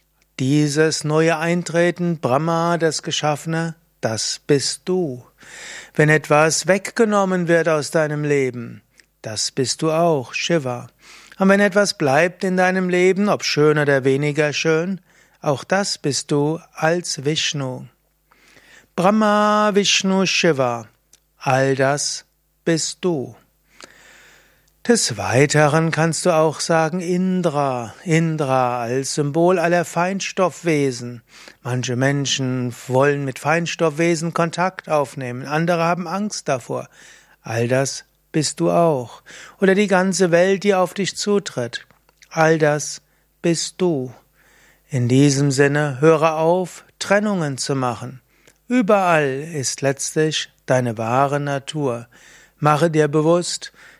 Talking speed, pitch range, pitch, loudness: 115 wpm, 140-175 Hz, 160 Hz, -19 LUFS